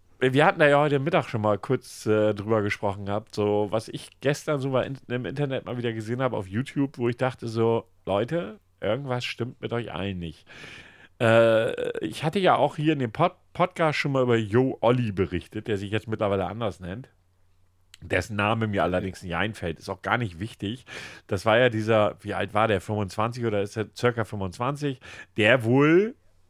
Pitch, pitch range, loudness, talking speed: 115 Hz, 100-130 Hz, -25 LUFS, 195 wpm